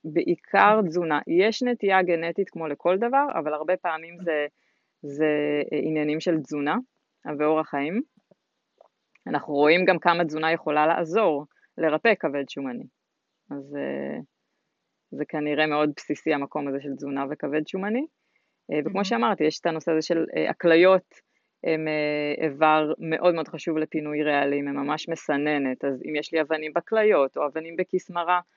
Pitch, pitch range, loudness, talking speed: 155 Hz, 150-175 Hz, -24 LUFS, 140 wpm